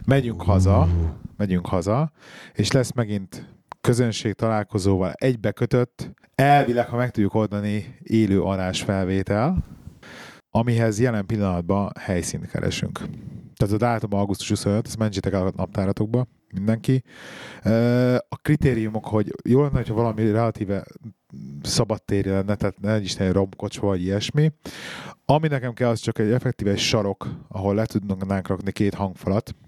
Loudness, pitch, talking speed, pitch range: -23 LUFS, 110 Hz, 135 wpm, 100-120 Hz